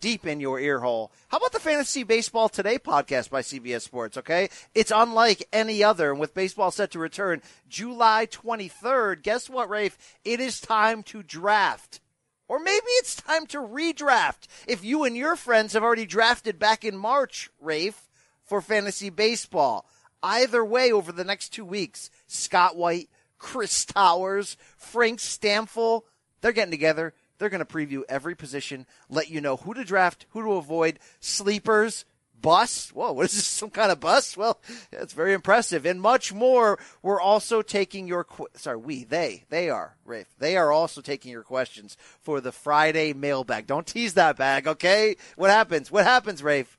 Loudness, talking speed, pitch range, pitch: -24 LUFS, 175 wpm, 155-225 Hz, 205 Hz